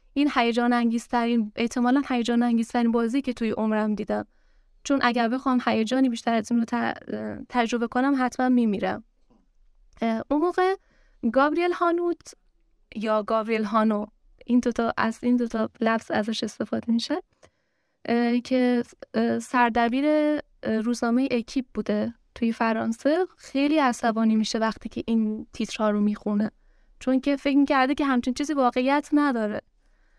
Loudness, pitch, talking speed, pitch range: -25 LUFS, 240 Hz, 130 wpm, 225-265 Hz